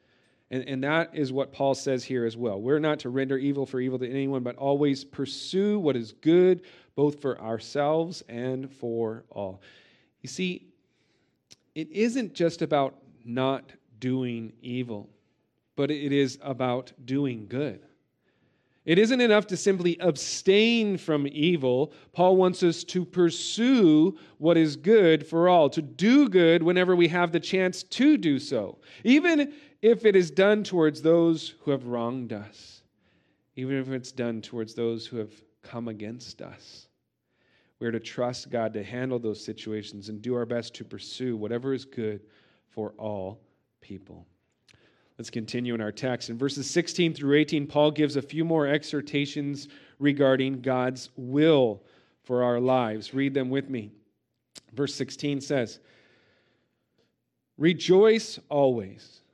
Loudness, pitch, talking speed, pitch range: -26 LUFS, 135 Hz, 150 wpm, 120-165 Hz